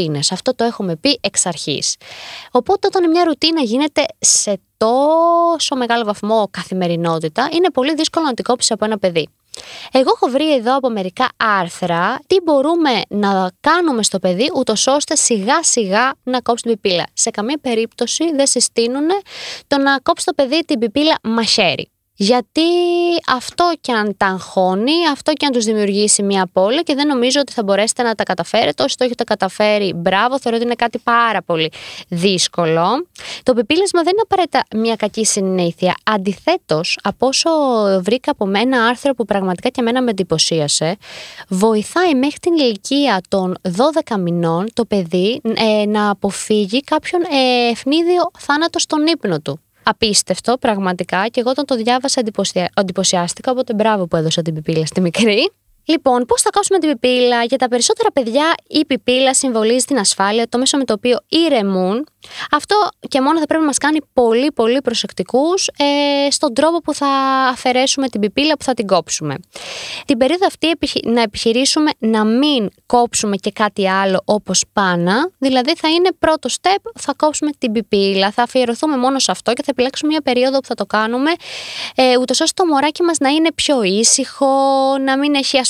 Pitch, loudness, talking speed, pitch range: 245 Hz, -15 LUFS, 170 wpm, 205-290 Hz